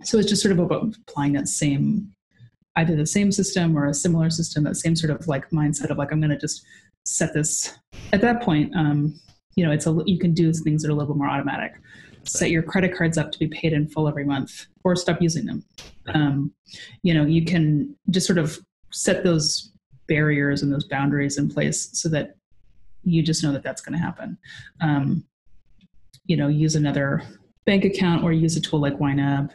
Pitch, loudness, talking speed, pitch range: 155 Hz, -22 LUFS, 215 wpm, 145-175 Hz